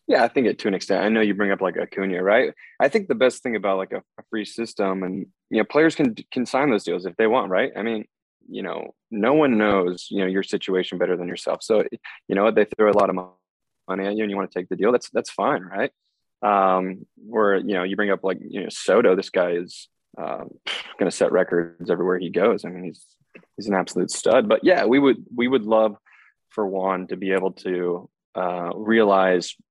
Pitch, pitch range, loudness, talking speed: 95 Hz, 90-110 Hz, -22 LUFS, 235 wpm